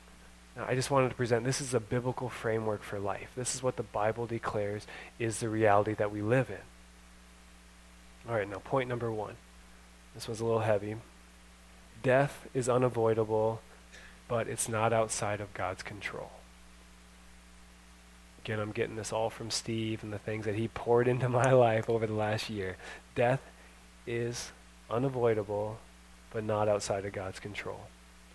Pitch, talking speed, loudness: 105 Hz, 160 wpm, -32 LUFS